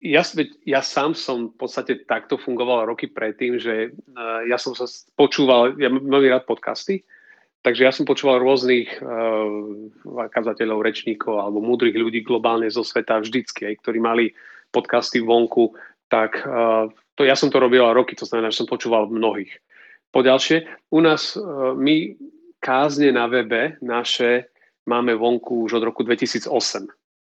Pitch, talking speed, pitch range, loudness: 120 Hz, 145 wpm, 115-135 Hz, -20 LUFS